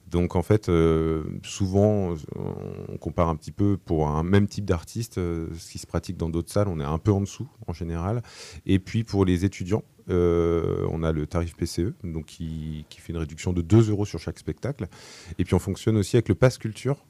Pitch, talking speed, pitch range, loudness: 90 Hz, 220 wpm, 85-105 Hz, -26 LUFS